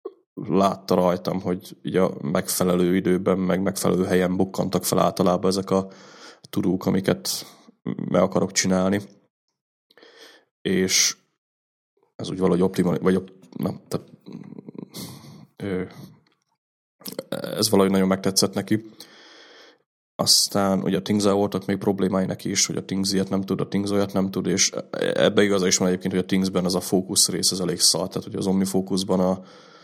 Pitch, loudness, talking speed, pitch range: 95 Hz, -22 LUFS, 150 wpm, 90-100 Hz